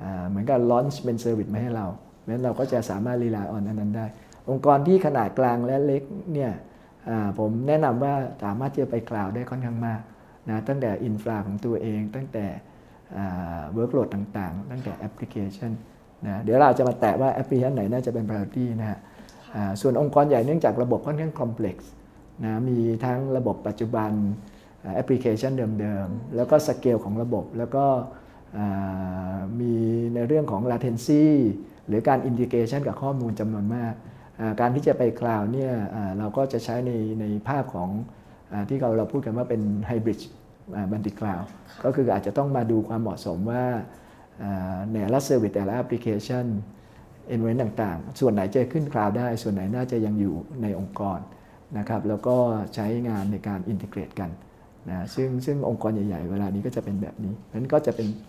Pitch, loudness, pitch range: 115 Hz, -26 LUFS, 105-125 Hz